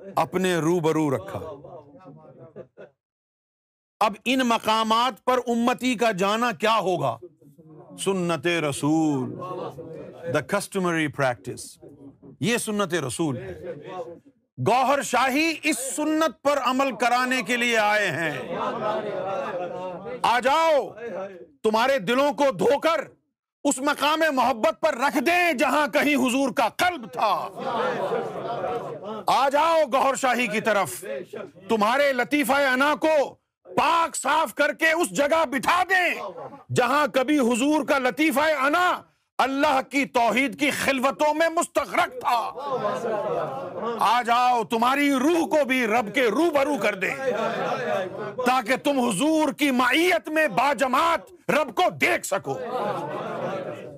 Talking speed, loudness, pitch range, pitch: 120 wpm, -23 LUFS, 205-295 Hz, 255 Hz